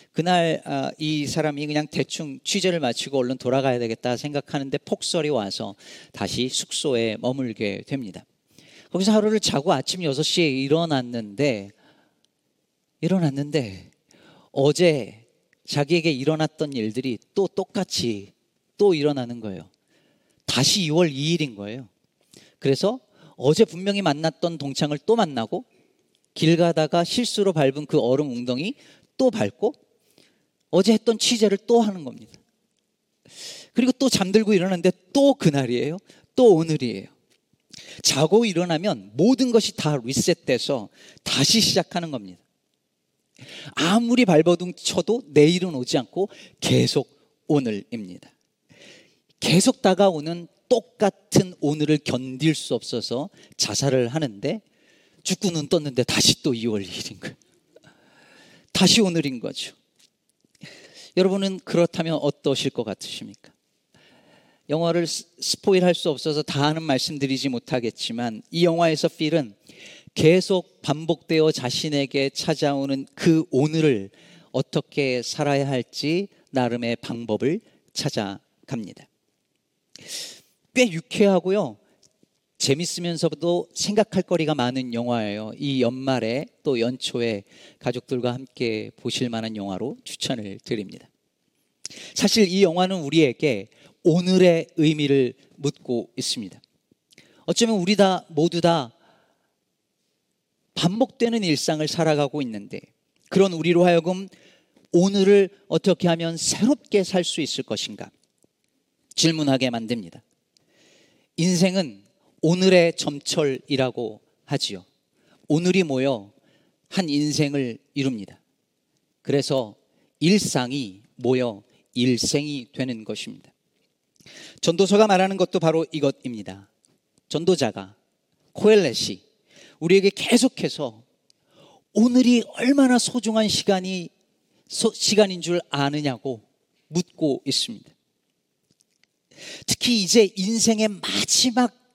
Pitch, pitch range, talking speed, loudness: 155 Hz, 130-185 Hz, 250 characters per minute, -22 LUFS